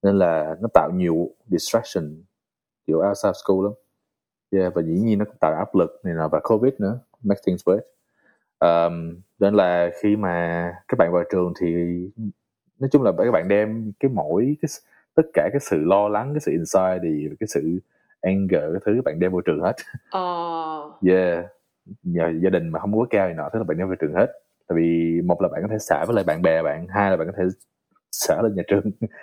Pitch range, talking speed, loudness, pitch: 85-105 Hz, 220 wpm, -22 LUFS, 95 Hz